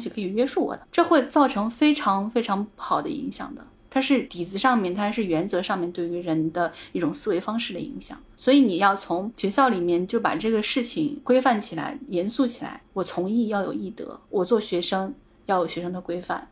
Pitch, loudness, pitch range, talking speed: 205 Hz, -24 LUFS, 180-260 Hz, 310 characters per minute